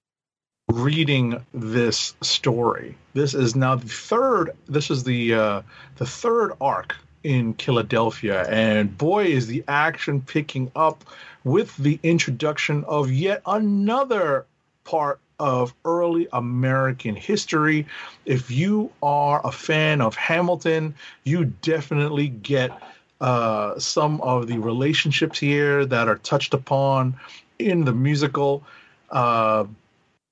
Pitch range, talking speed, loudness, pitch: 125-155 Hz, 115 wpm, -22 LUFS, 140 Hz